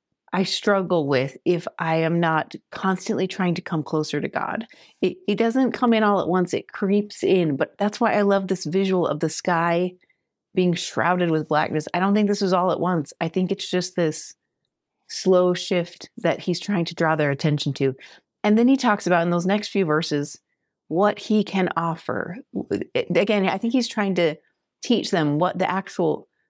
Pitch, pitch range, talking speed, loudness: 180 Hz, 165-200 Hz, 195 wpm, -22 LUFS